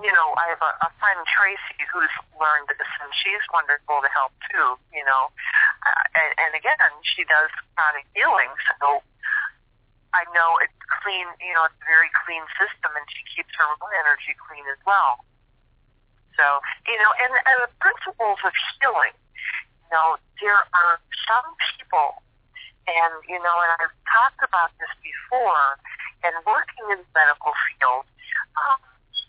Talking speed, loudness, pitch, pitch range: 160 wpm, -21 LUFS, 170 Hz, 150-205 Hz